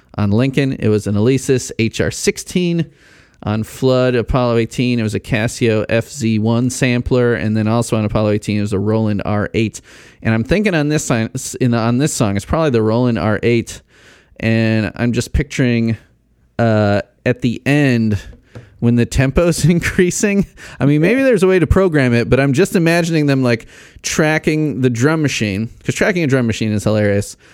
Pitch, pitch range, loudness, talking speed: 120 Hz, 110-145 Hz, -16 LUFS, 175 wpm